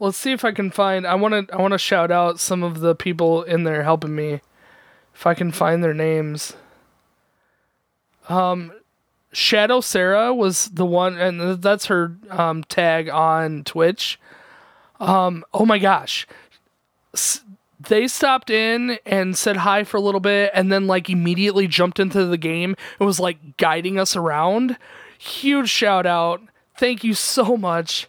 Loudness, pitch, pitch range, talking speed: -19 LUFS, 185 Hz, 170-205 Hz, 165 wpm